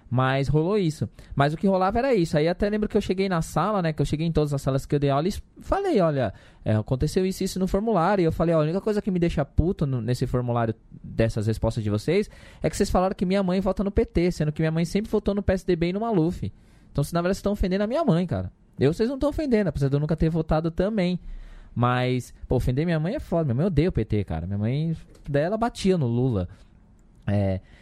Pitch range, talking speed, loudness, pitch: 130-195 Hz, 260 wpm, -25 LUFS, 160 Hz